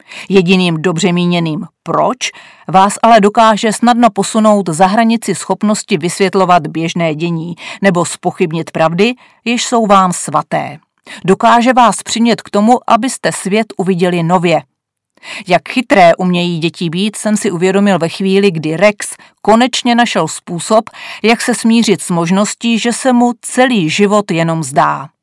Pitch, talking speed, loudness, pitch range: 195 Hz, 140 wpm, -12 LUFS, 175-230 Hz